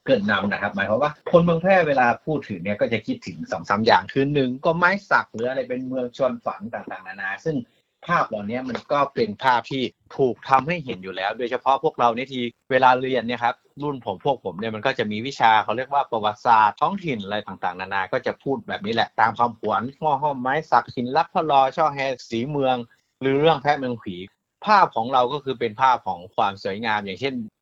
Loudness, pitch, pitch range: -22 LUFS, 130 Hz, 115-145 Hz